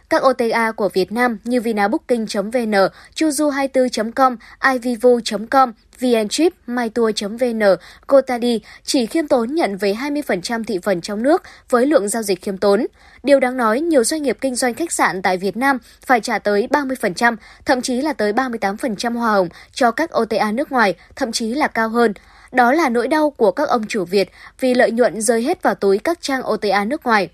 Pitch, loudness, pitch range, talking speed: 240 Hz, -18 LUFS, 210-270 Hz, 185 wpm